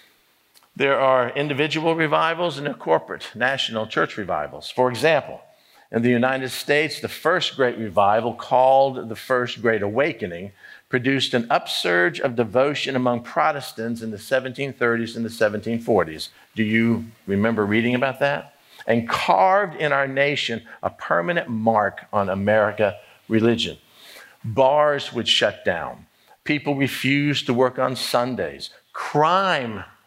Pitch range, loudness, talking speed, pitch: 115-140 Hz, -21 LUFS, 130 wpm, 125 Hz